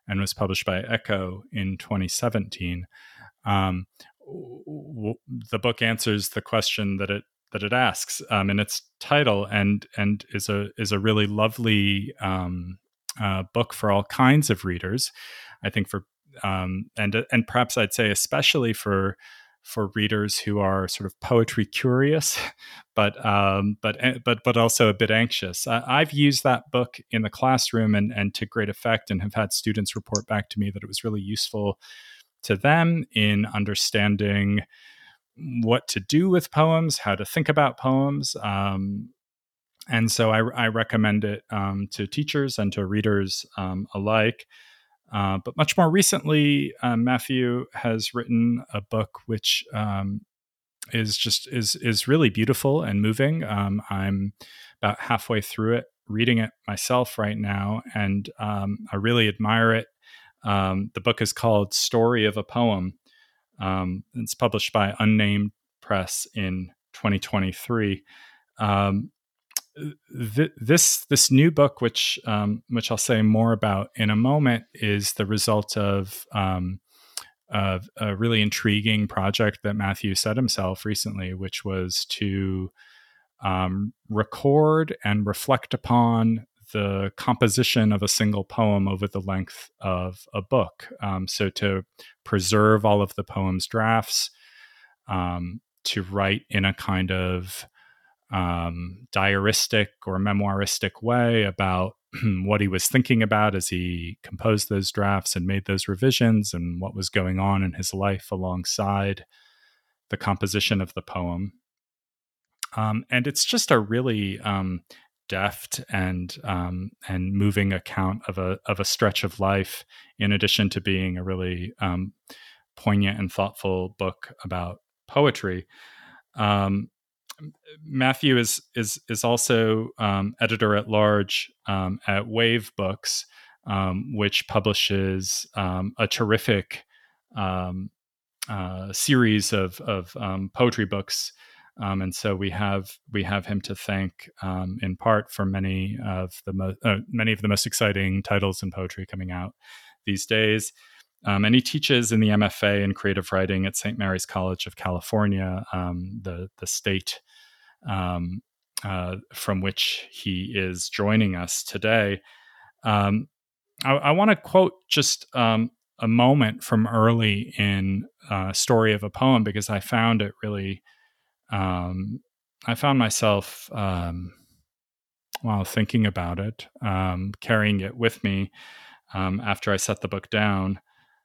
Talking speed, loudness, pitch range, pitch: 145 wpm, -24 LUFS, 95-115 Hz, 105 Hz